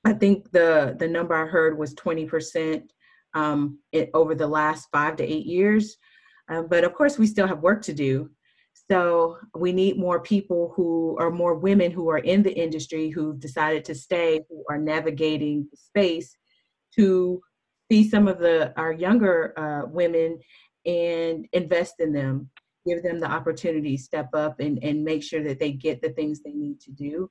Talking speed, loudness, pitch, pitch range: 185 wpm, -24 LUFS, 165 Hz, 155-175 Hz